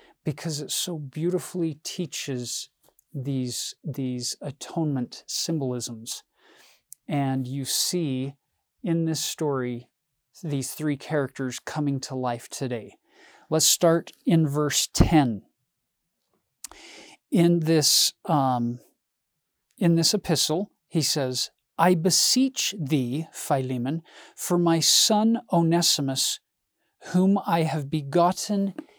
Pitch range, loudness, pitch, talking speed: 135-170 Hz, -24 LUFS, 155 Hz, 95 wpm